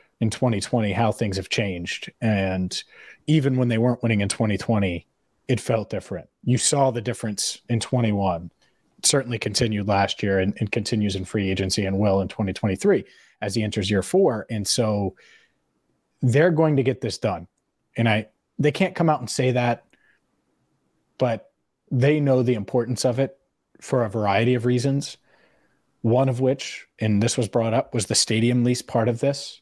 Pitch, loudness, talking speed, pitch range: 115 Hz, -23 LUFS, 175 wpm, 105-125 Hz